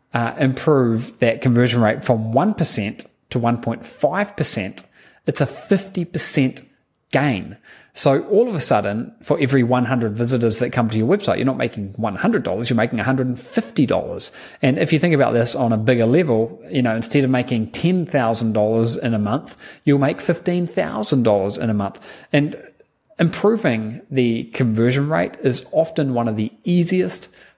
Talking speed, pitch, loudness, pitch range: 150 wpm, 125 Hz, -19 LUFS, 115-150 Hz